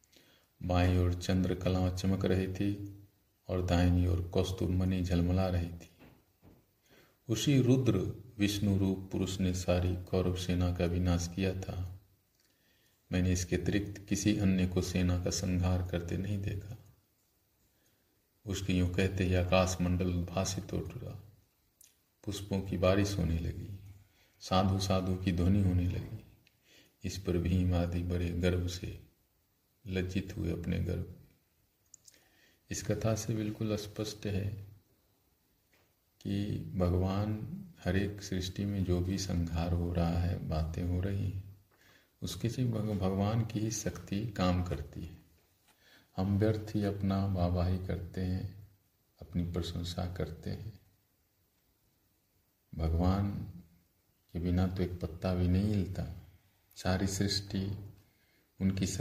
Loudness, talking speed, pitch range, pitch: -33 LUFS, 120 wpm, 90-100 Hz, 95 Hz